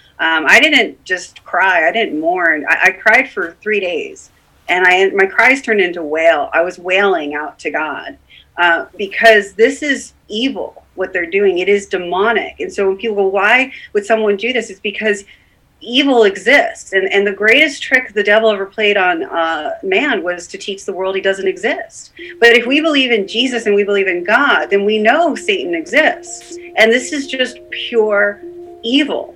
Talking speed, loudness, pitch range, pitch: 190 wpm, -13 LUFS, 195-310 Hz, 225 Hz